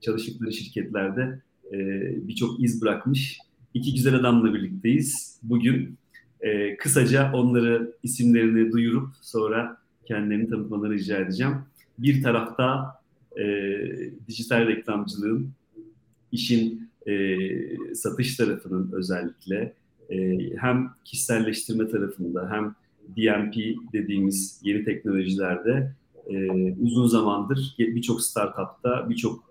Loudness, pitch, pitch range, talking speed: -25 LUFS, 115 Hz, 105-125 Hz, 95 wpm